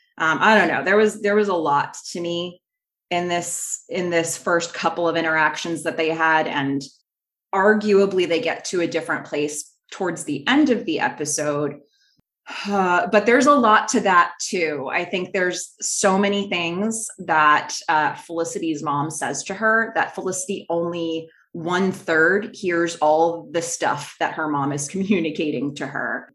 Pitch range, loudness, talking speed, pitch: 160-195 Hz, -21 LUFS, 170 wpm, 170 Hz